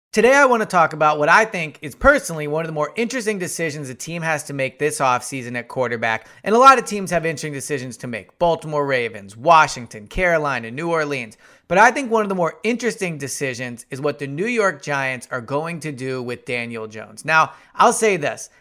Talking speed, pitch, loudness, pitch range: 220 wpm, 150 Hz, -19 LUFS, 130-180 Hz